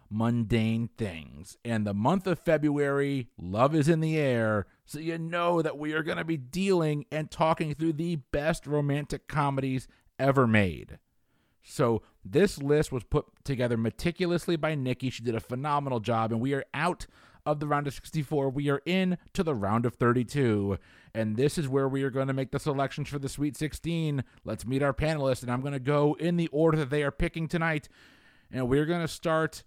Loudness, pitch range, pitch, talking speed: -29 LUFS, 120-160 Hz, 140 Hz, 200 wpm